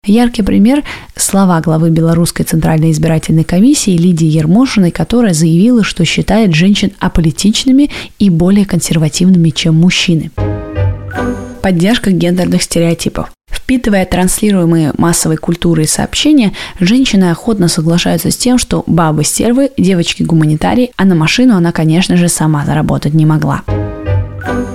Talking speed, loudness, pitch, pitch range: 120 wpm, -10 LUFS, 175 Hz, 160-200 Hz